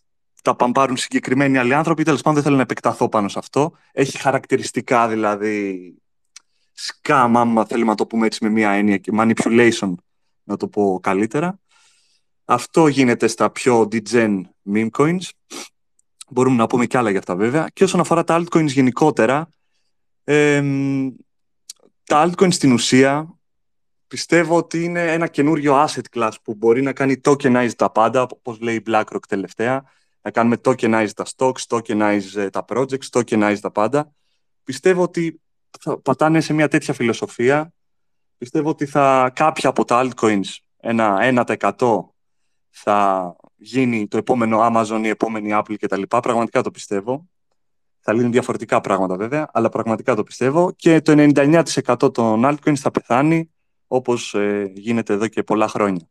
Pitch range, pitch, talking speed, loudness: 110-145 Hz, 120 Hz, 150 wpm, -18 LUFS